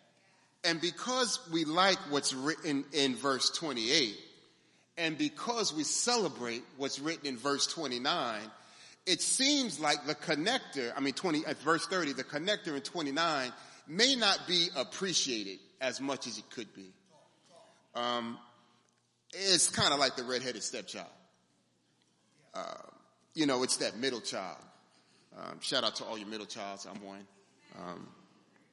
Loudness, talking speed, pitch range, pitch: -32 LUFS, 145 wpm, 120-175 Hz, 145 Hz